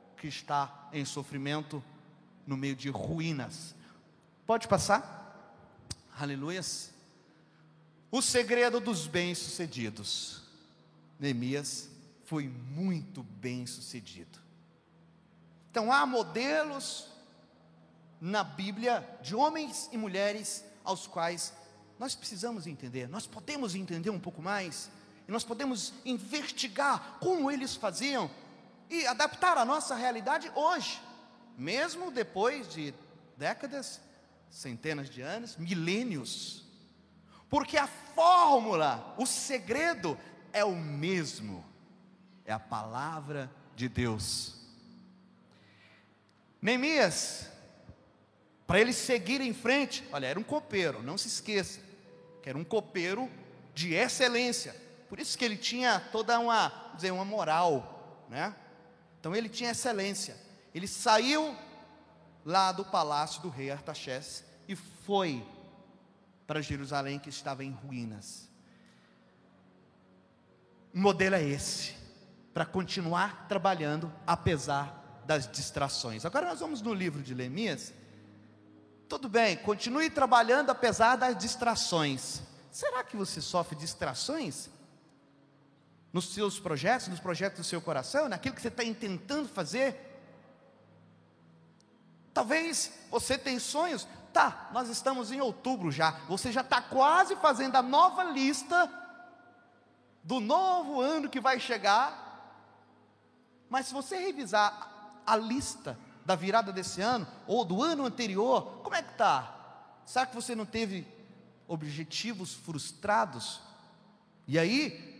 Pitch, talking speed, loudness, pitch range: 195 Hz, 115 wpm, -32 LUFS, 150-245 Hz